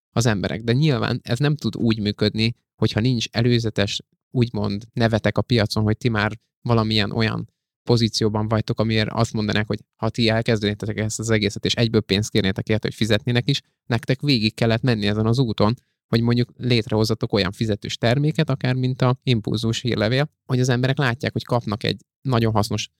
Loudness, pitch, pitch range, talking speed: -21 LUFS, 115 Hz, 110-125 Hz, 175 wpm